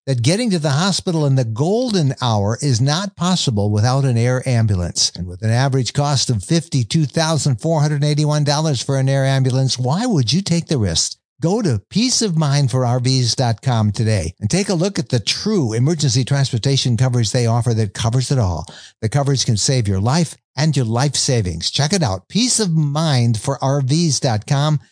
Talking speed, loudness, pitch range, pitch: 160 wpm, -17 LUFS, 120-155 Hz, 135 Hz